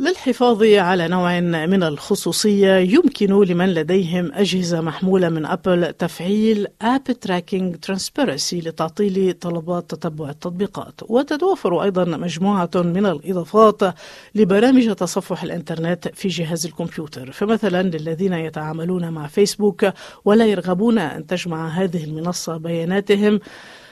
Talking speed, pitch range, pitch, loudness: 110 wpm, 170-205 Hz, 185 Hz, -19 LUFS